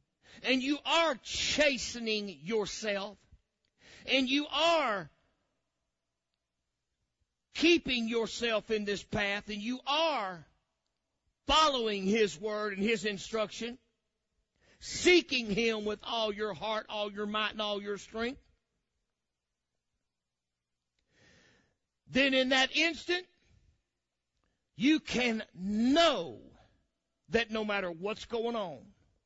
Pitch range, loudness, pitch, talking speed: 195-255 Hz, -31 LUFS, 215 Hz, 100 wpm